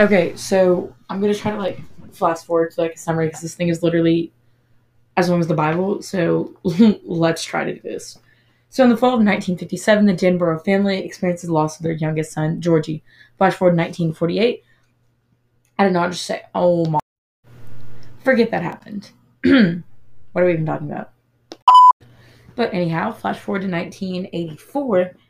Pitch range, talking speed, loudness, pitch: 160-195 Hz, 175 wpm, -18 LUFS, 175 Hz